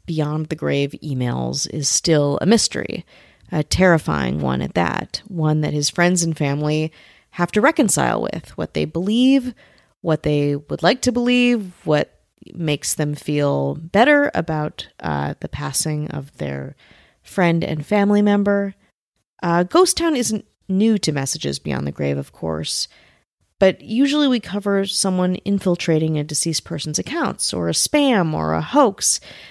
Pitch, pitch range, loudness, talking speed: 155 Hz, 145-200 Hz, -19 LUFS, 155 wpm